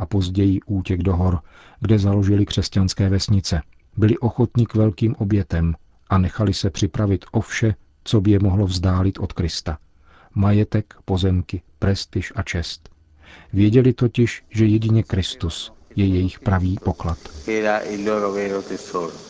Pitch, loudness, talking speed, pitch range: 100 Hz, -21 LUFS, 125 wpm, 90-105 Hz